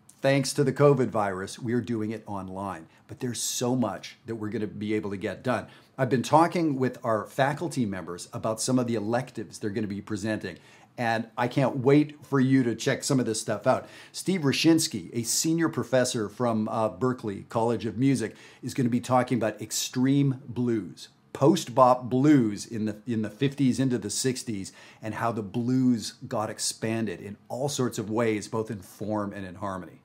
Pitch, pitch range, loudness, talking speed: 120 Hz, 110-130 Hz, -27 LUFS, 200 wpm